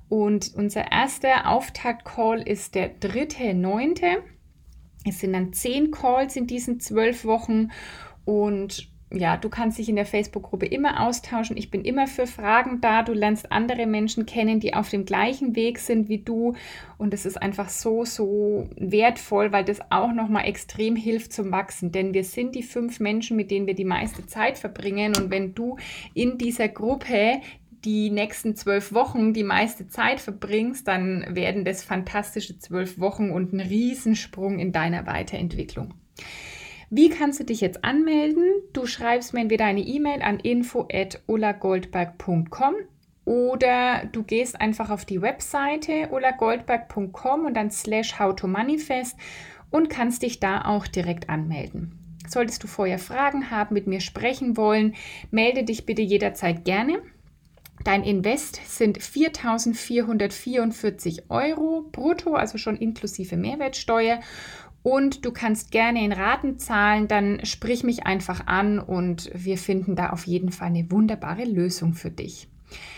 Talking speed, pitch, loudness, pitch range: 150 wpm, 220 Hz, -24 LUFS, 200-245 Hz